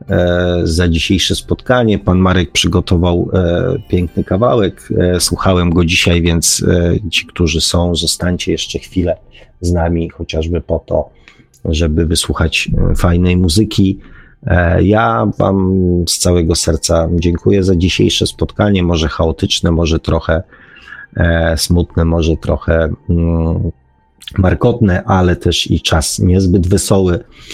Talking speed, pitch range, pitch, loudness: 125 wpm, 85-95 Hz, 90 Hz, -13 LUFS